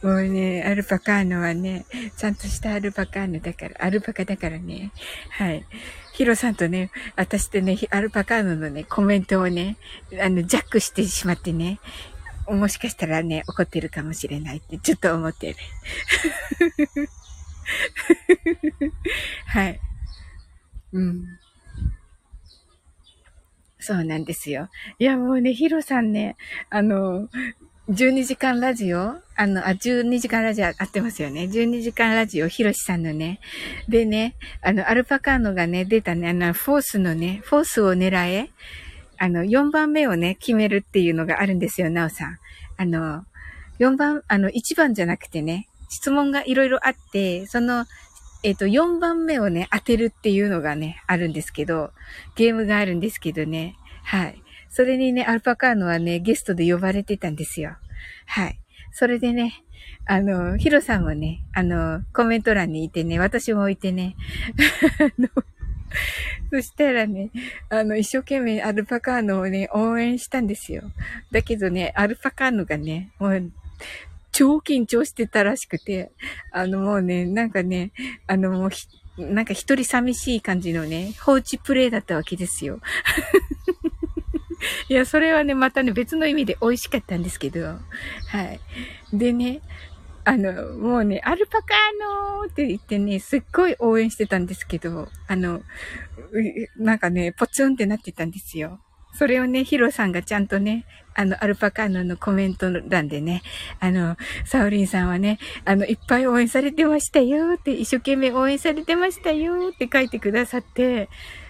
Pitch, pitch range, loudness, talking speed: 205 Hz, 175-255 Hz, -22 LUFS, 315 characters per minute